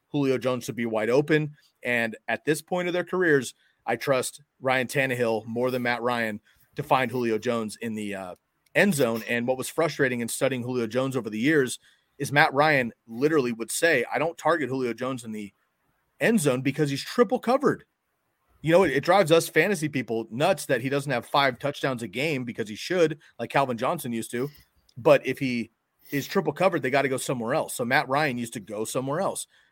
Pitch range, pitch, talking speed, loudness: 120-150 Hz, 130 Hz, 210 wpm, -25 LUFS